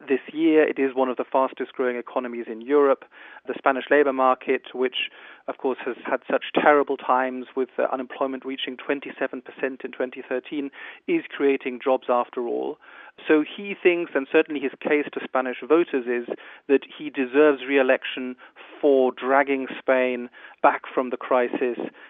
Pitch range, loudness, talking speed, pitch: 130-145 Hz, -24 LUFS, 160 wpm, 135 Hz